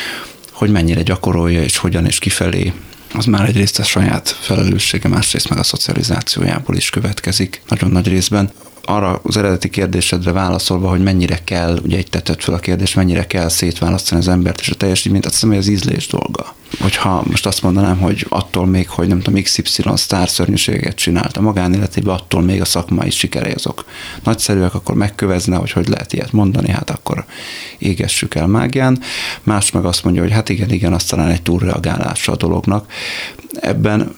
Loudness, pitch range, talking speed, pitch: -15 LUFS, 90-100 Hz, 175 wpm, 95 Hz